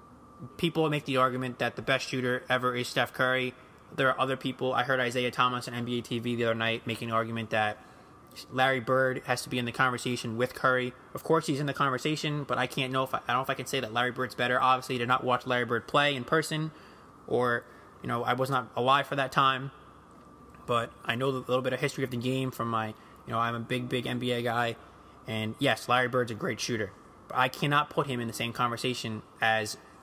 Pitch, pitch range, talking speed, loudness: 125 Hz, 120-135 Hz, 240 wpm, -29 LUFS